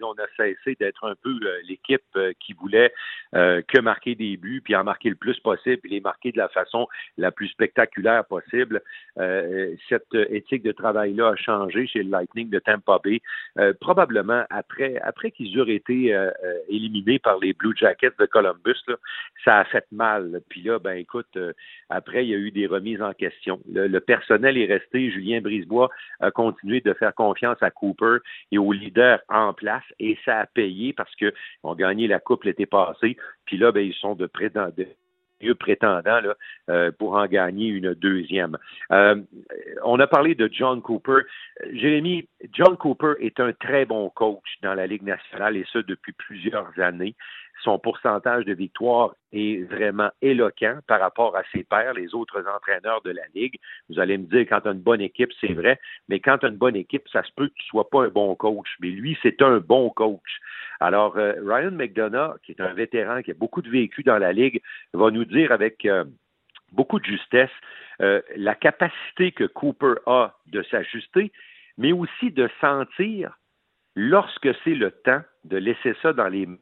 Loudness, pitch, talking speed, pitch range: -22 LUFS, 115 Hz, 195 wpm, 100-165 Hz